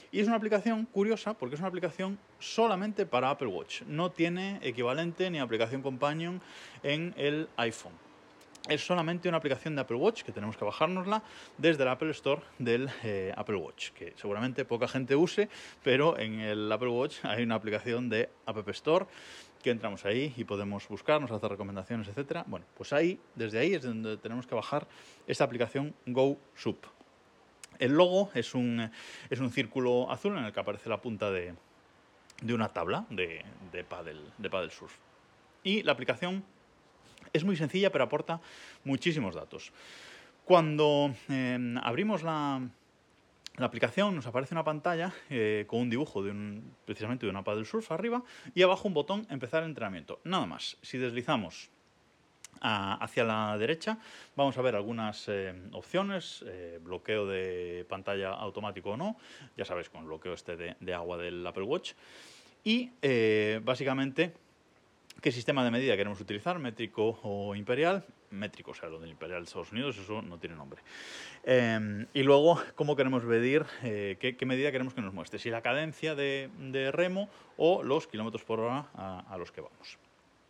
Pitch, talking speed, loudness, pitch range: 130 Hz, 170 wpm, -32 LUFS, 110-160 Hz